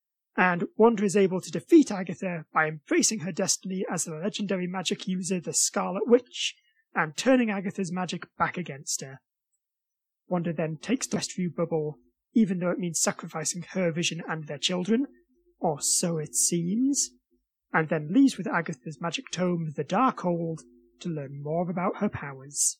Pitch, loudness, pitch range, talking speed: 180 Hz, -27 LUFS, 160-200 Hz, 165 wpm